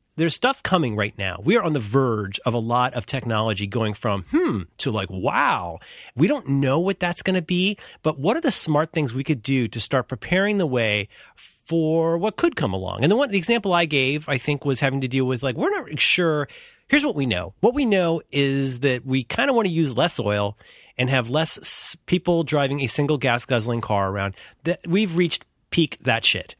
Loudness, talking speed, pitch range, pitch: -22 LUFS, 225 wpm, 120-175 Hz, 140 Hz